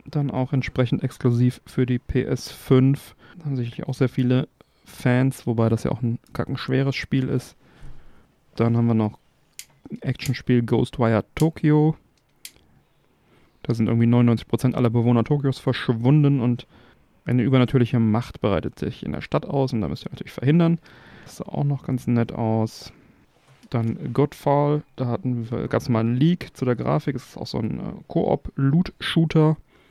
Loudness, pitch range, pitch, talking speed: -23 LUFS, 120-140 Hz, 125 Hz, 160 wpm